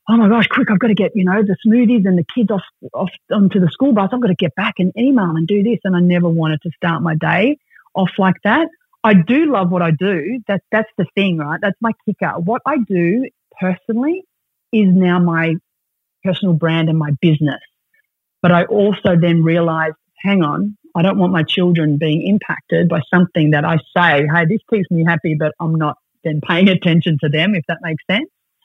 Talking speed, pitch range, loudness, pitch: 220 wpm, 165-215 Hz, -15 LUFS, 185 Hz